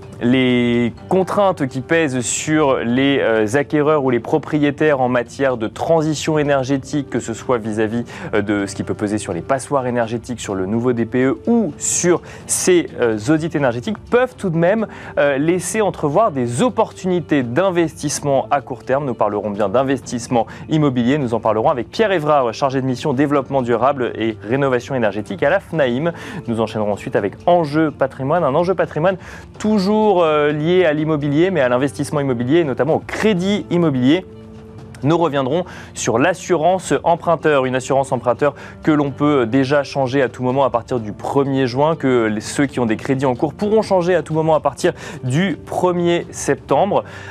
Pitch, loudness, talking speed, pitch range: 140 Hz, -18 LUFS, 170 wpm, 120-160 Hz